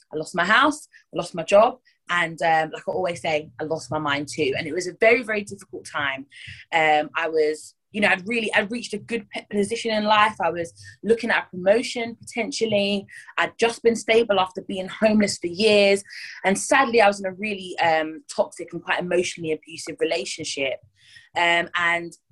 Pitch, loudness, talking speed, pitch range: 190 Hz, -22 LUFS, 195 wpm, 165-220 Hz